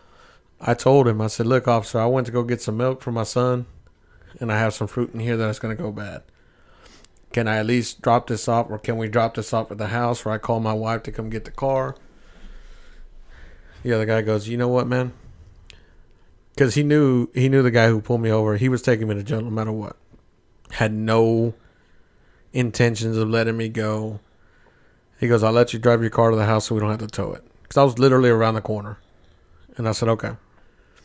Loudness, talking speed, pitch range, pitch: -21 LUFS, 230 wpm, 110-120 Hz, 115 Hz